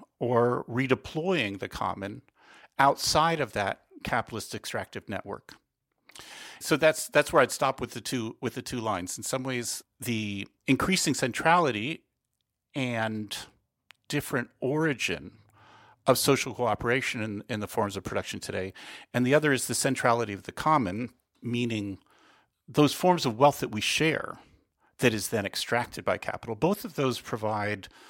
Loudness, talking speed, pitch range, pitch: -28 LUFS, 145 wpm, 110-140 Hz, 125 Hz